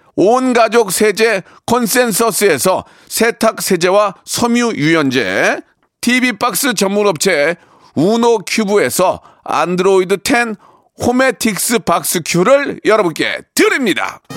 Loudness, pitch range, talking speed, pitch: -13 LUFS, 195-240 Hz, 235 characters per minute, 225 Hz